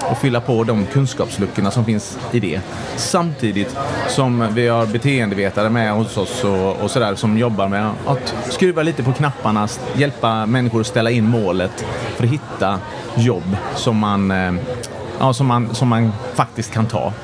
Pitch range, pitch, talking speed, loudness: 105-125 Hz, 115 Hz, 165 wpm, -18 LUFS